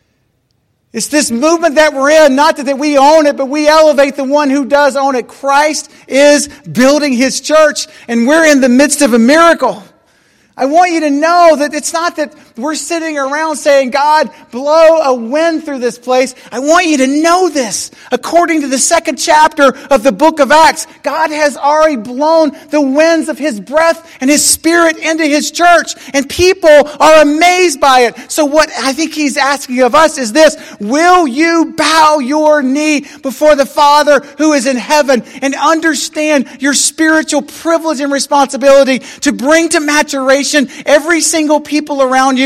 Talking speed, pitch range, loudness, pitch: 180 wpm, 275-315 Hz, -9 LUFS, 295 Hz